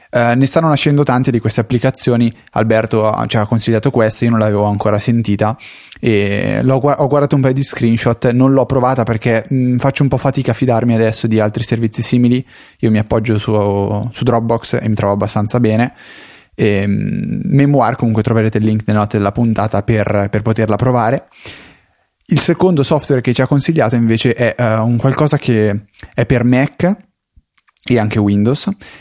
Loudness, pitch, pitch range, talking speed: -14 LUFS, 120 Hz, 110-130 Hz, 180 wpm